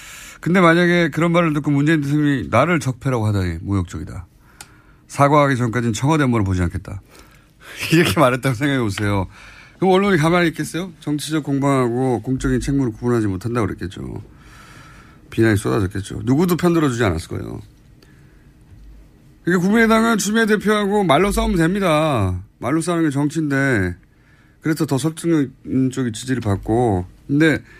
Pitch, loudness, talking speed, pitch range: 135 Hz, -18 LUFS, 380 characters per minute, 115-165 Hz